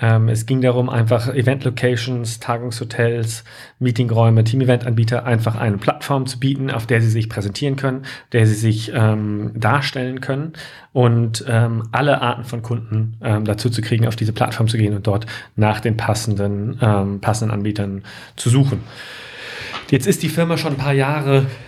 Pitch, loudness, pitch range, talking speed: 120 Hz, -19 LUFS, 110-130 Hz, 160 wpm